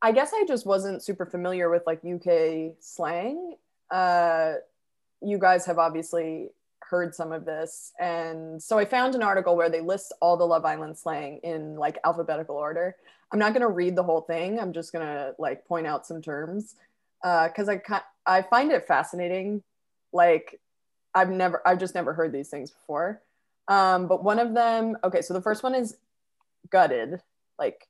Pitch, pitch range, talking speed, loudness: 180 Hz, 165-205 Hz, 180 wpm, -26 LUFS